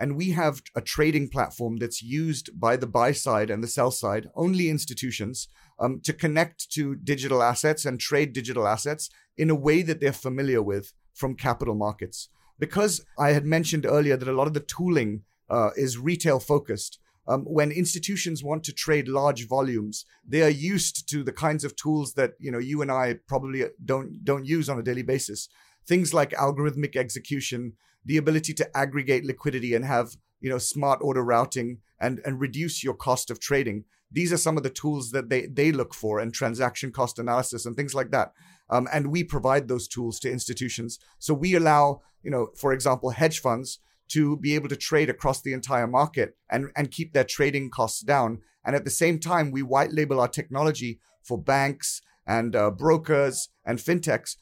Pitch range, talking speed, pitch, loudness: 125-150 Hz, 195 wpm, 140 Hz, -26 LUFS